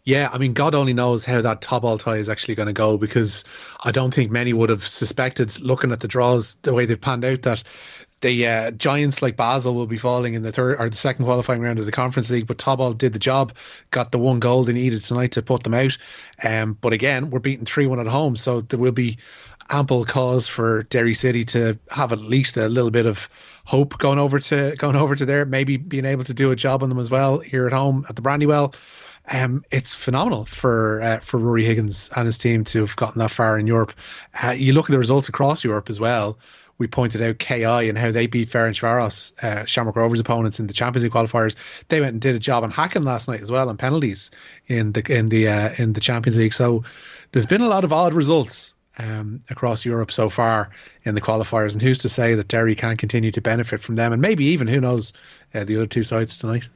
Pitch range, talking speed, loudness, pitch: 115-130 Hz, 240 wpm, -20 LUFS, 120 Hz